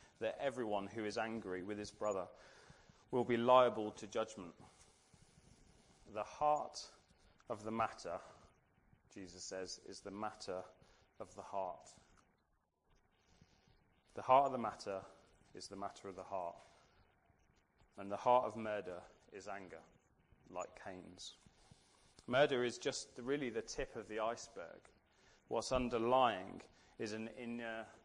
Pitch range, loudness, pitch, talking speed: 90-115 Hz, -40 LUFS, 105 Hz, 130 wpm